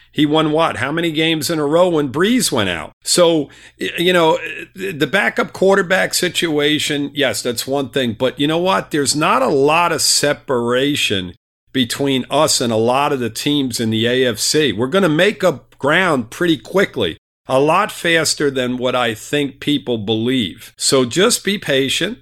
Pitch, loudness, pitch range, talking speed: 145 Hz, -16 LUFS, 125-165 Hz, 180 wpm